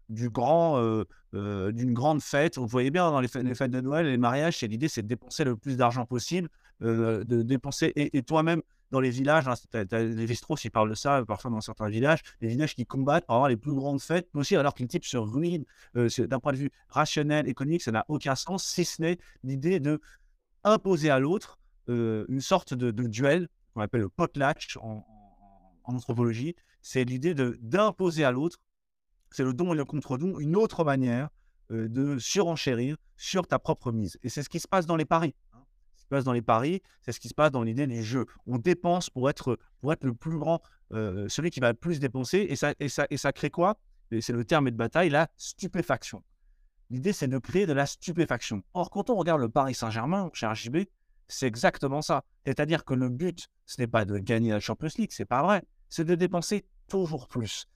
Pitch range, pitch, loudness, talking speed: 120-165 Hz, 135 Hz, -28 LUFS, 230 wpm